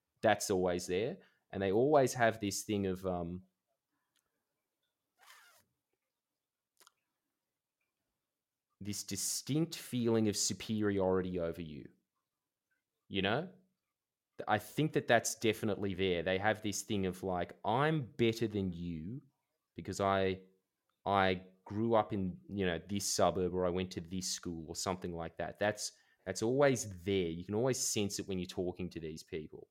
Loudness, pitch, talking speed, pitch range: -35 LUFS, 100 Hz, 145 wpm, 90-110 Hz